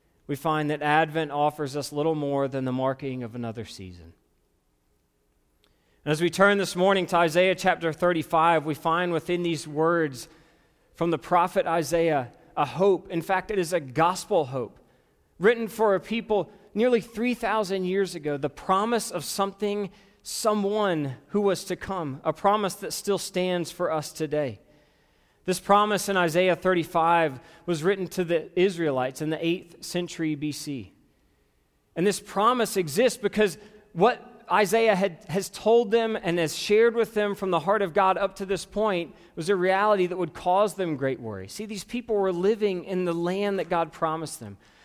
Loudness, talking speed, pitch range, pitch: -25 LUFS, 170 wpm, 155-200 Hz, 175 Hz